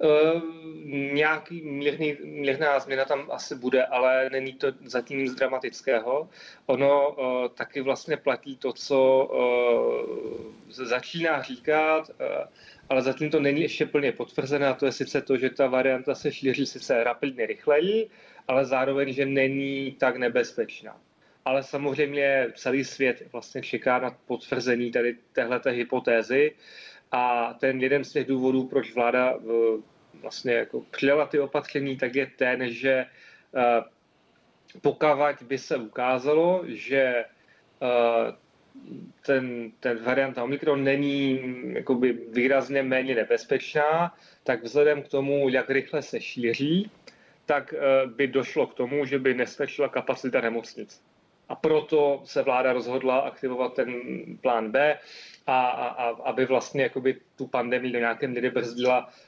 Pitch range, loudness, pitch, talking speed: 125-145 Hz, -26 LUFS, 135 Hz, 135 wpm